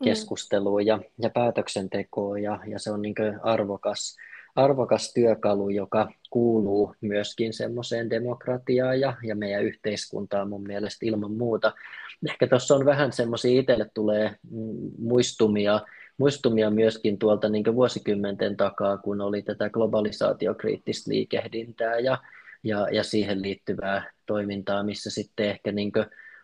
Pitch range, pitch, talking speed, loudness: 100-115 Hz, 110 Hz, 125 wpm, -26 LUFS